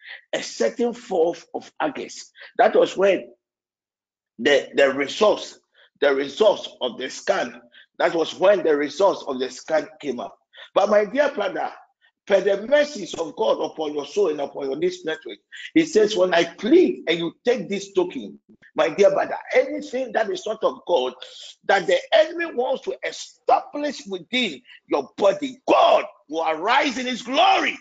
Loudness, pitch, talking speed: -22 LUFS, 255 Hz, 170 wpm